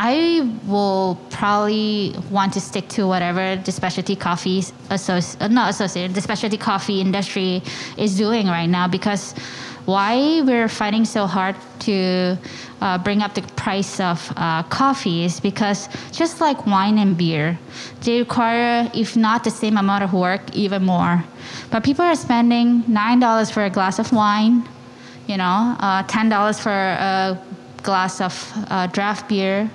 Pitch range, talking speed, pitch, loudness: 185-220 Hz, 155 wpm, 200 Hz, -19 LUFS